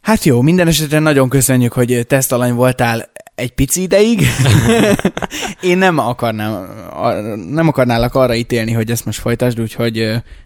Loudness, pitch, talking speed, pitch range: -14 LUFS, 125 Hz, 140 wpm, 115-150 Hz